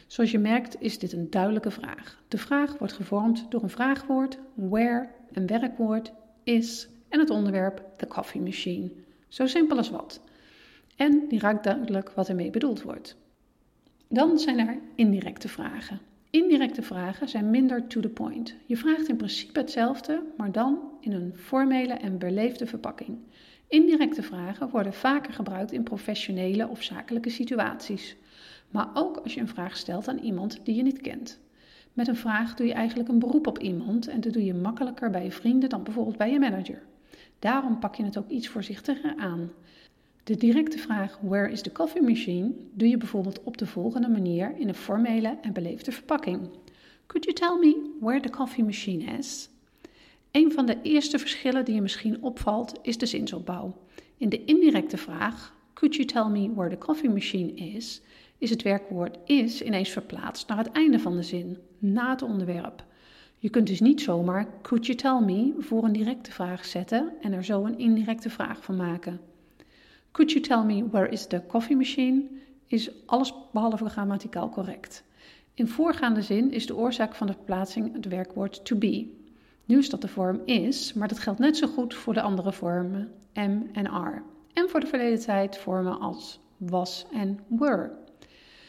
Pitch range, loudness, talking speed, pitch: 200-265 Hz, -27 LUFS, 180 wpm, 230 Hz